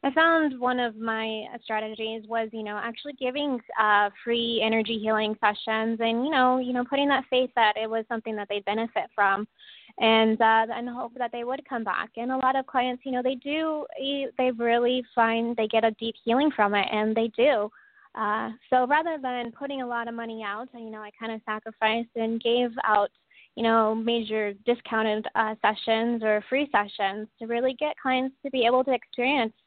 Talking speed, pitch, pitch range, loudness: 205 wpm, 230 Hz, 220-255 Hz, -26 LUFS